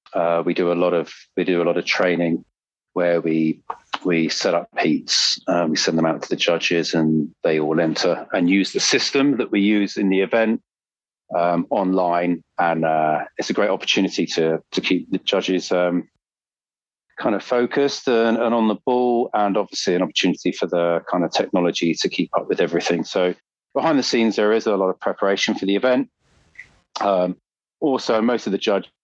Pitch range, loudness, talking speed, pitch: 85-105 Hz, -20 LUFS, 195 wpm, 90 Hz